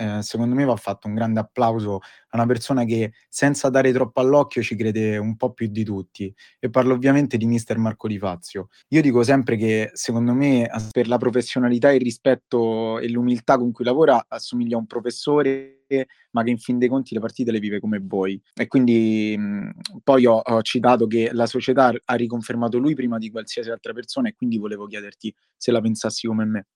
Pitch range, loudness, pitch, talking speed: 110-130 Hz, -21 LUFS, 120 Hz, 200 wpm